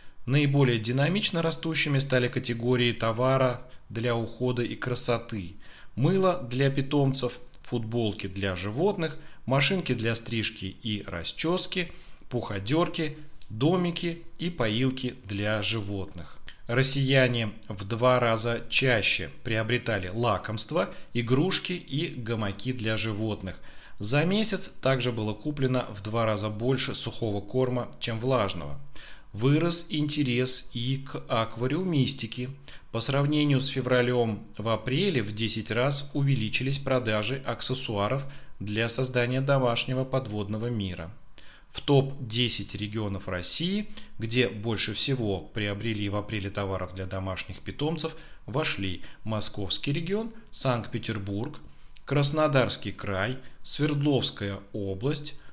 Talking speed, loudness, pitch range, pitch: 105 wpm, -28 LUFS, 110-140 Hz, 120 Hz